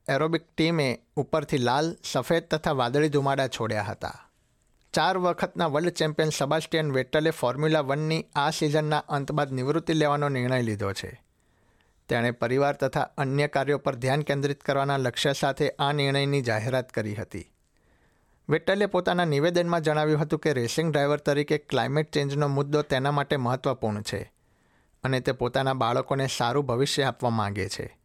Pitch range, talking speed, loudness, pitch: 130-155 Hz, 145 wpm, -26 LUFS, 140 Hz